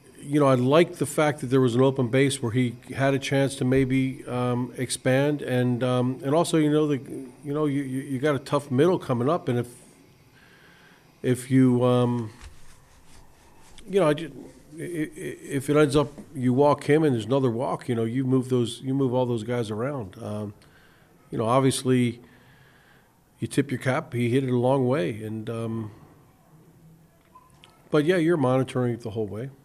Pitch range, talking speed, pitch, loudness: 125-145 Hz, 190 wpm, 130 Hz, -24 LUFS